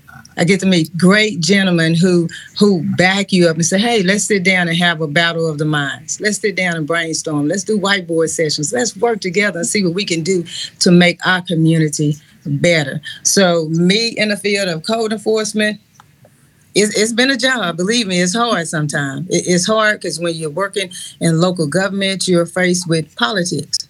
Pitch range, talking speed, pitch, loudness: 160-200 Hz, 195 wpm, 180 Hz, -15 LUFS